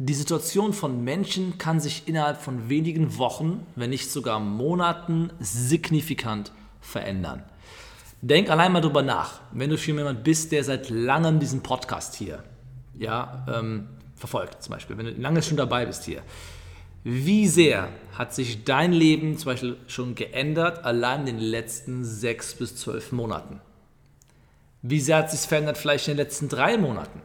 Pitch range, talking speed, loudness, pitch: 115-155 Hz, 160 wpm, -25 LUFS, 130 Hz